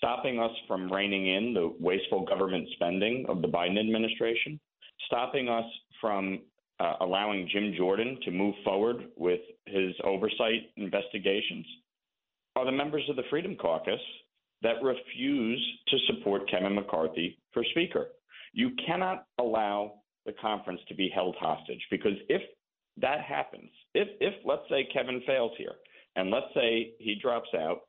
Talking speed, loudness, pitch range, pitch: 145 wpm, -31 LUFS, 100-140 Hz, 115 Hz